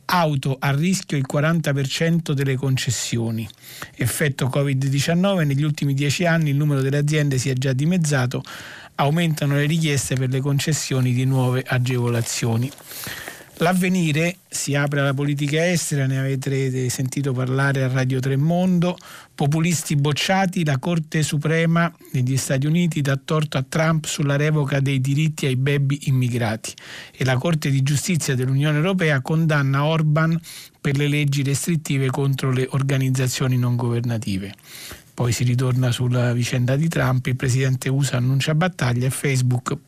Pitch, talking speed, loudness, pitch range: 140 Hz, 140 wpm, -21 LUFS, 130-155 Hz